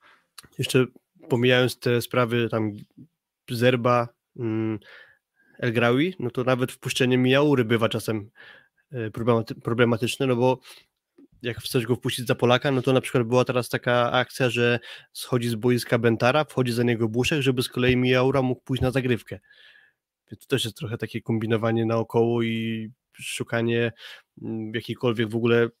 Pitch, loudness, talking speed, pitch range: 120 Hz, -24 LUFS, 145 wpm, 115-130 Hz